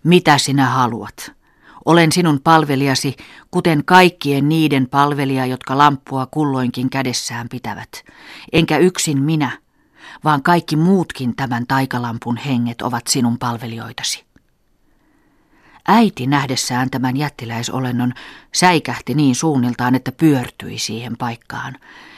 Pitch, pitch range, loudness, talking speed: 135 Hz, 125-150 Hz, -17 LUFS, 105 wpm